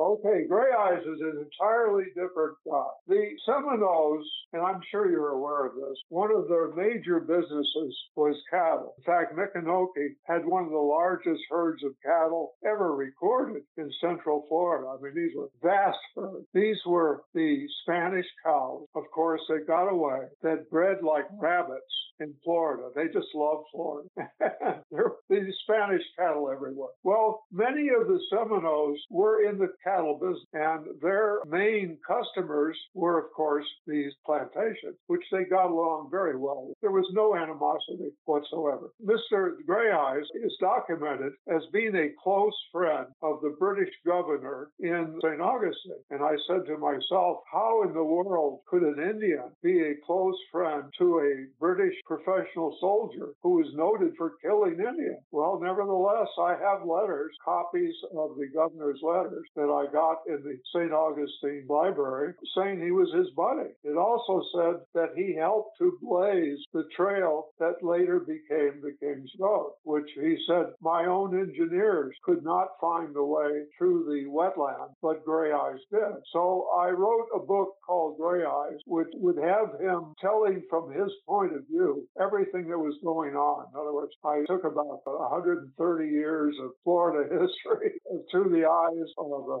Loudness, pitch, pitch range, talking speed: -28 LUFS, 170 Hz, 155-205 Hz, 160 wpm